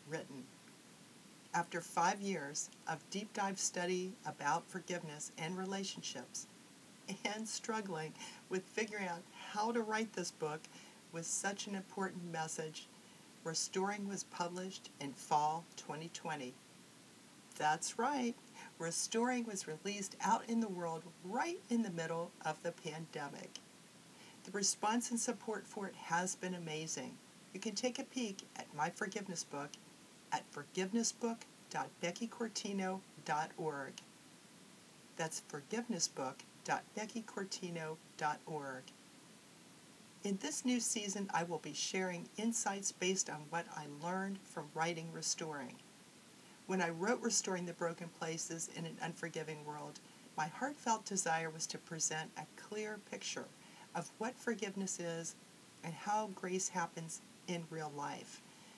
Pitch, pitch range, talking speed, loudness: 185 Hz, 165-215 Hz, 120 wpm, -41 LUFS